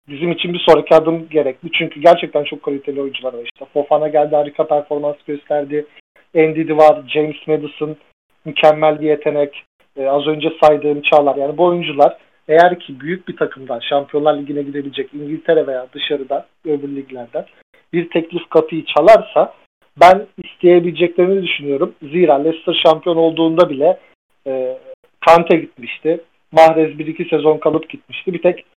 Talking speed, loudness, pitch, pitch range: 145 wpm, -15 LUFS, 155 Hz, 145-170 Hz